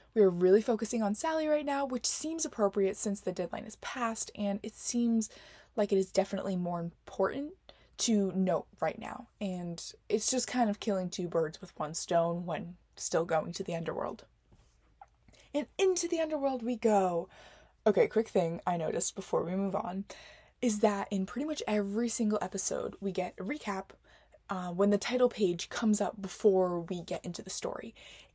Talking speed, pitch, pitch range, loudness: 180 wpm, 200 Hz, 185-235 Hz, -32 LUFS